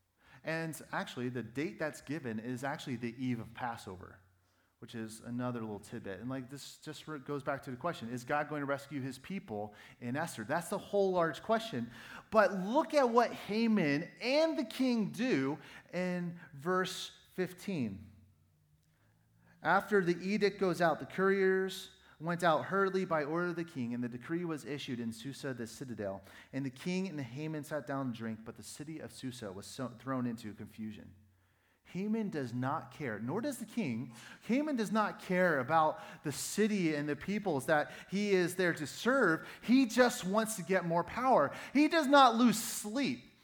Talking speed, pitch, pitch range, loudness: 180 wpm, 150 Hz, 125-190 Hz, -34 LUFS